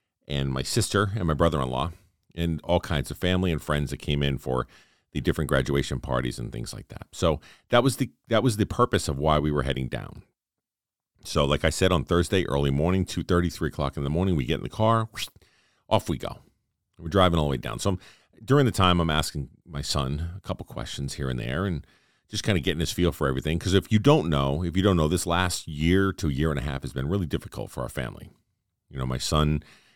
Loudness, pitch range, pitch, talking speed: -26 LUFS, 70-95 Hz, 85 Hz, 240 wpm